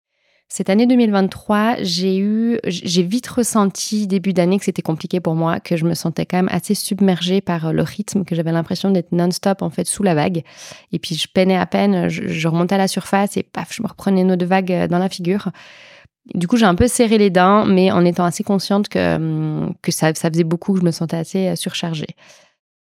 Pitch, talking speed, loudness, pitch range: 185 Hz, 215 wpm, -18 LUFS, 175-200 Hz